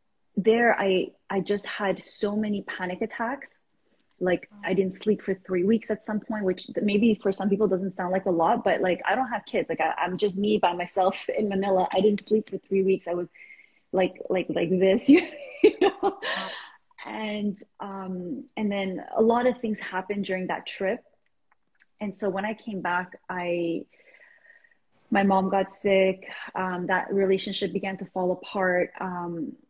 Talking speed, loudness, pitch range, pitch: 180 wpm, -26 LUFS, 185-215 Hz, 195 Hz